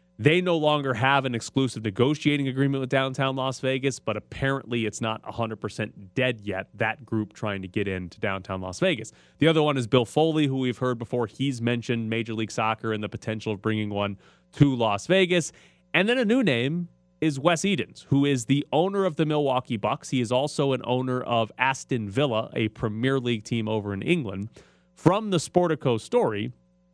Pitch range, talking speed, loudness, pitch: 110-145 Hz, 195 wpm, -25 LUFS, 125 Hz